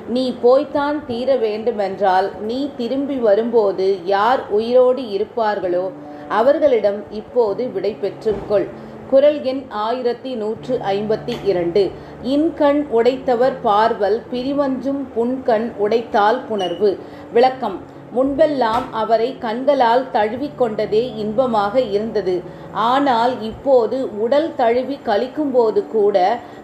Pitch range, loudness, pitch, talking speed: 210-260 Hz, -18 LUFS, 235 Hz, 90 wpm